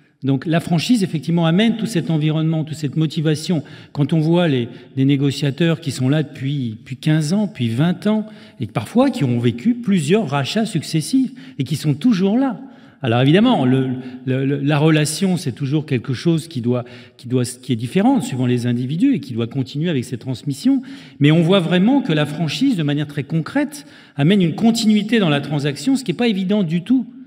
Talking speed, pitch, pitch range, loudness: 200 wpm, 155 Hz, 135-200 Hz, -18 LUFS